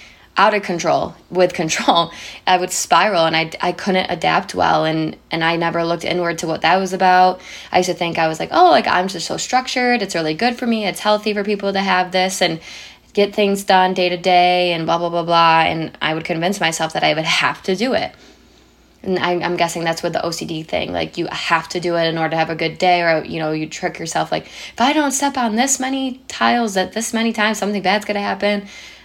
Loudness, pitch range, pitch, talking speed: -17 LUFS, 165-205 Hz, 180 Hz, 245 wpm